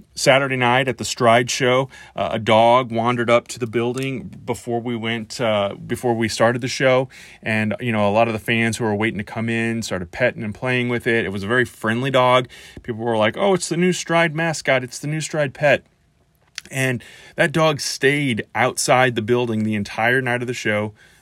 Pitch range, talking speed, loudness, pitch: 115-130 Hz, 215 wpm, -19 LUFS, 120 Hz